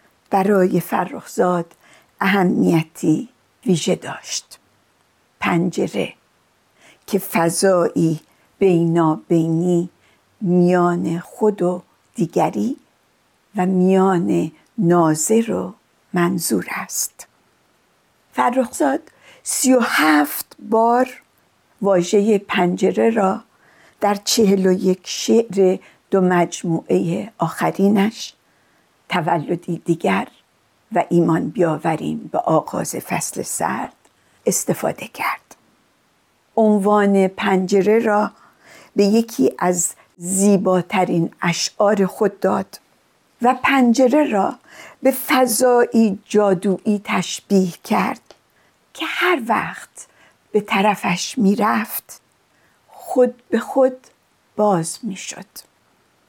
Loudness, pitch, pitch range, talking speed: -18 LUFS, 195 Hz, 175-220 Hz, 80 wpm